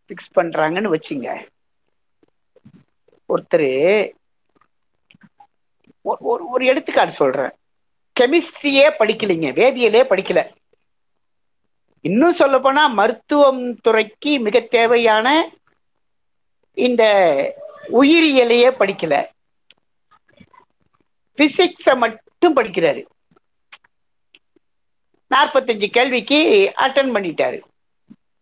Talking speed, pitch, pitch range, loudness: 60 wpm, 275 Hz, 235-340 Hz, -16 LUFS